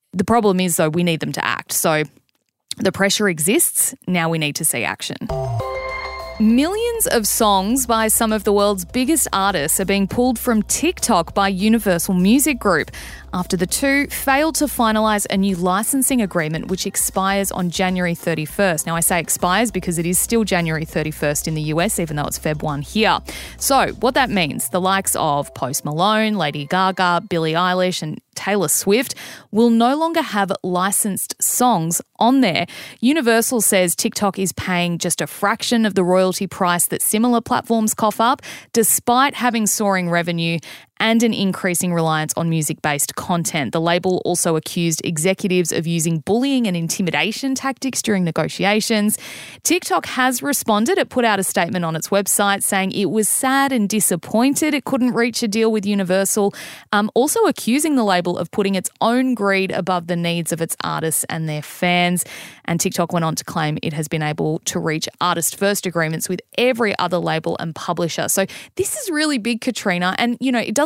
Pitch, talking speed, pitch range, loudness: 195 Hz, 180 wpm, 170-225 Hz, -18 LUFS